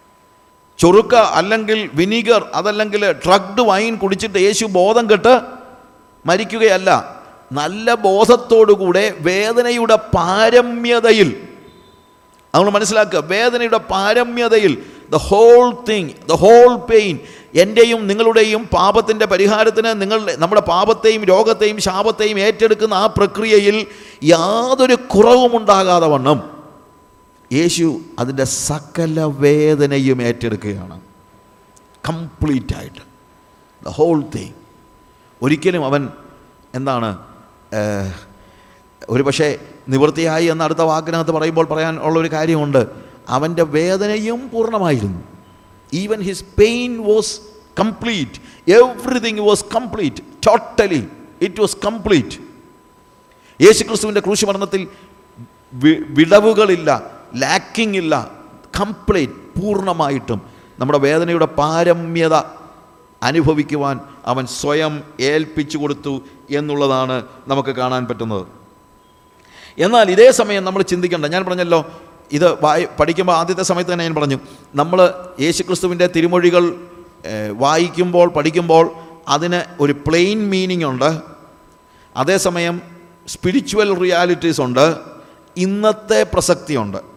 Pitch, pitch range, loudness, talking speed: 175 Hz, 145-210 Hz, -15 LUFS, 90 wpm